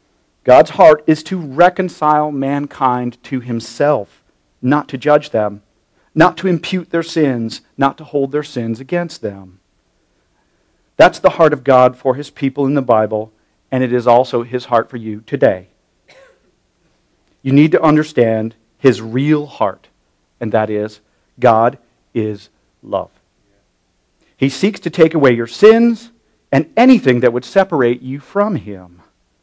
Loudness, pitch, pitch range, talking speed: -14 LUFS, 130 Hz, 110-150 Hz, 145 wpm